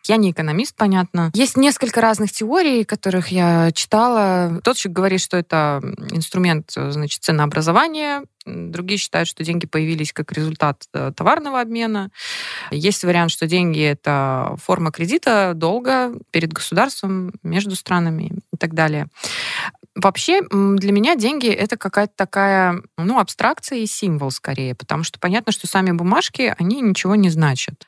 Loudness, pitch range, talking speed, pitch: -18 LUFS, 165-215 Hz, 140 wpm, 185 Hz